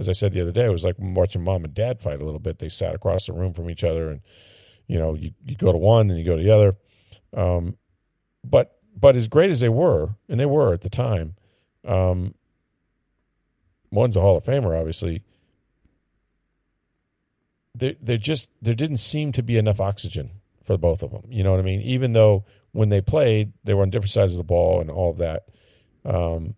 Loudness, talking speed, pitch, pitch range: -22 LUFS, 220 wpm, 100 Hz, 90-115 Hz